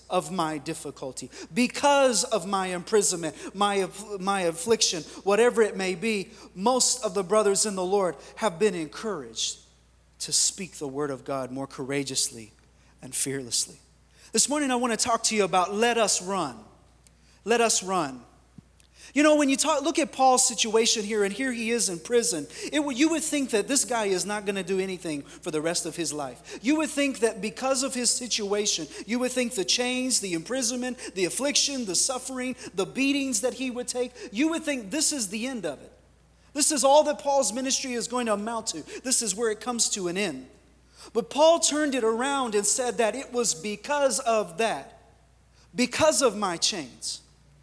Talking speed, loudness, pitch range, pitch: 195 wpm, -25 LUFS, 185-255 Hz, 225 Hz